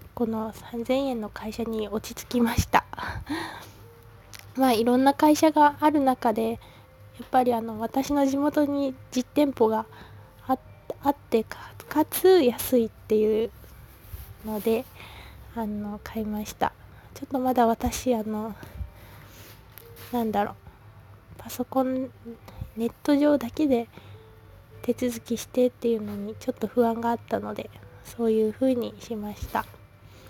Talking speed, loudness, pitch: 245 characters per minute, -26 LUFS, 230 Hz